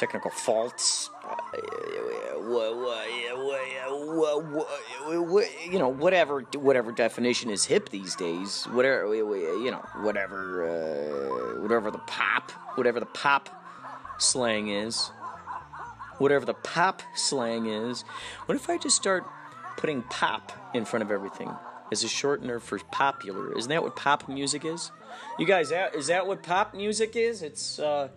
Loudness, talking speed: -28 LUFS, 150 wpm